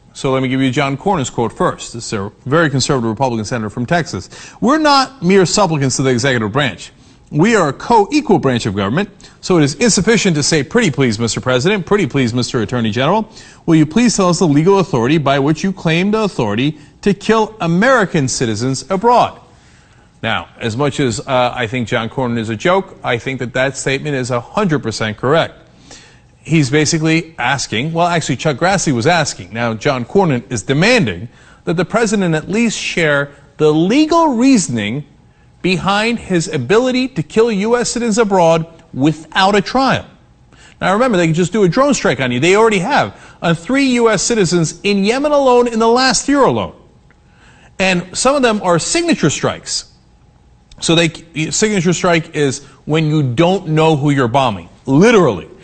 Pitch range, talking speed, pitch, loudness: 130-200 Hz, 180 wpm, 160 Hz, -14 LUFS